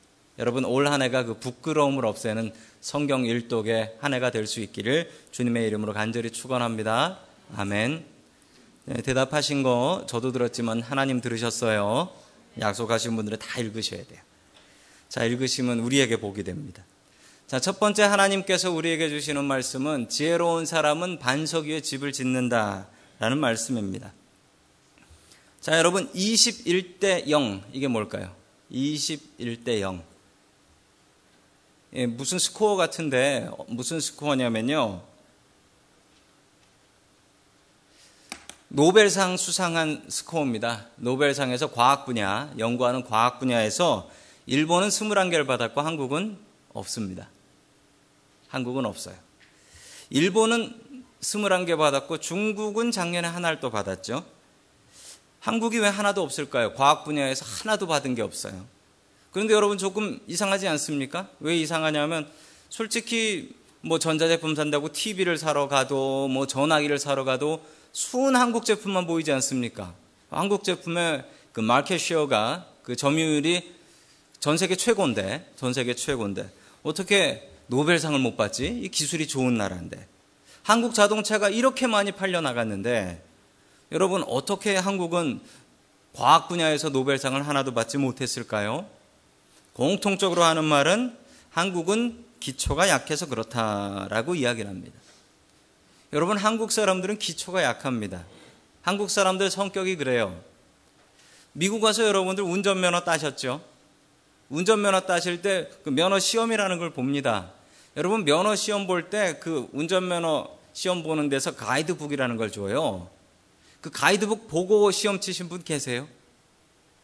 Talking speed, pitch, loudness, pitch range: 285 characters per minute, 145 Hz, -25 LUFS, 120-185 Hz